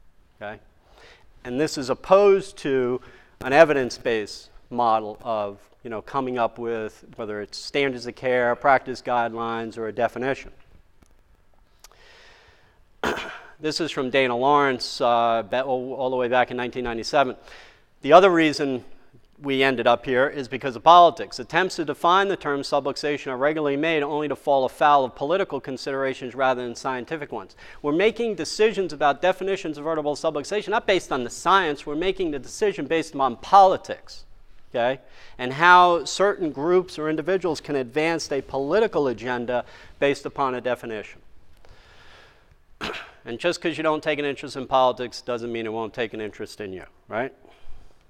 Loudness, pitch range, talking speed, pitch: -23 LUFS, 120-155 Hz, 155 wpm, 135 Hz